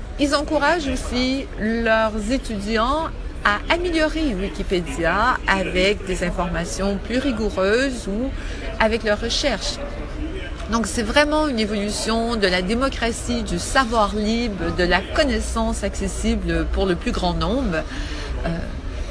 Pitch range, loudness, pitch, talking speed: 190-255 Hz, -21 LUFS, 220 Hz, 120 wpm